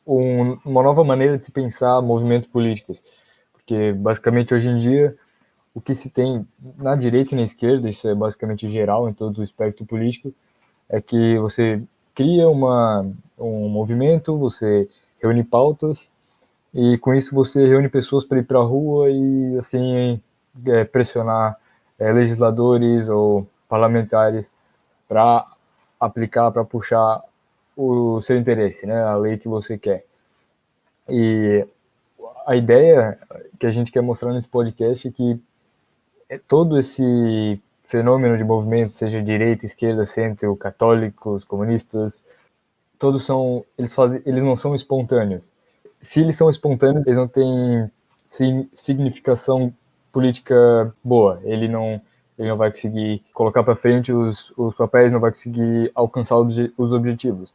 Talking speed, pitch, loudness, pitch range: 140 wpm, 120 Hz, -19 LUFS, 110-130 Hz